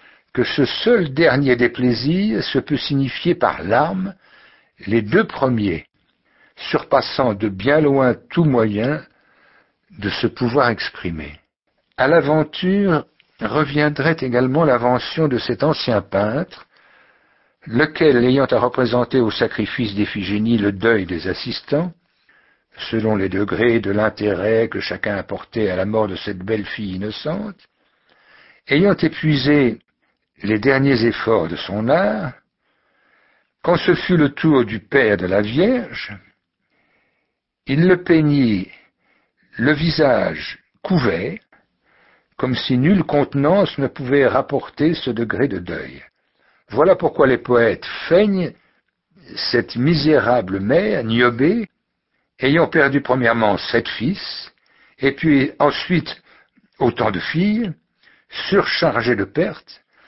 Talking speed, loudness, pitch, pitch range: 120 wpm, -18 LUFS, 135 Hz, 115-160 Hz